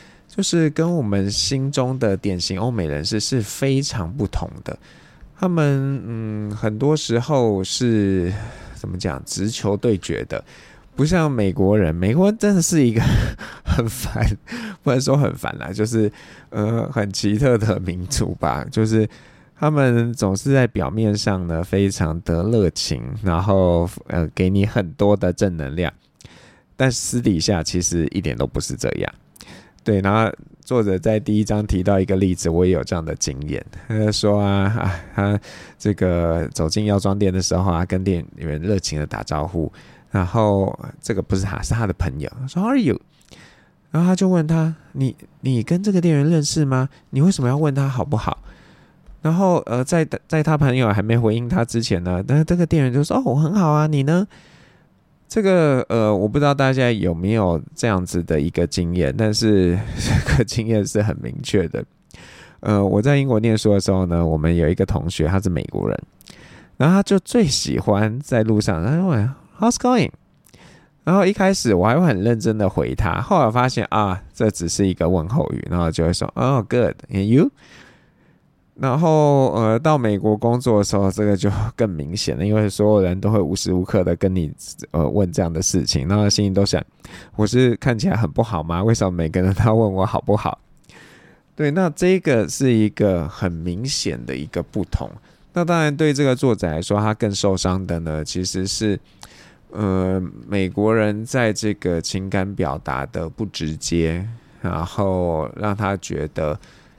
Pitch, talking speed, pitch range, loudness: 105 Hz, 265 characters per minute, 95-130 Hz, -20 LUFS